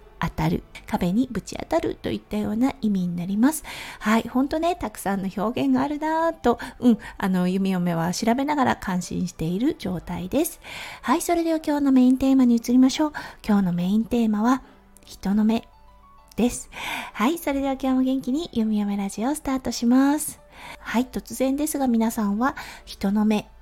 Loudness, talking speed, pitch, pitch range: -23 LUFS, 360 characters per minute, 235 Hz, 205-275 Hz